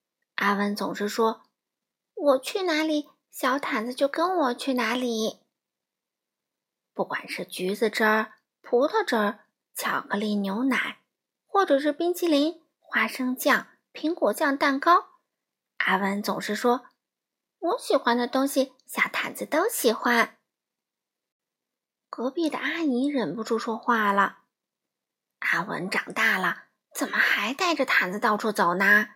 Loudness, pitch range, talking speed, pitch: -25 LUFS, 220-310 Hz, 190 characters per minute, 255 Hz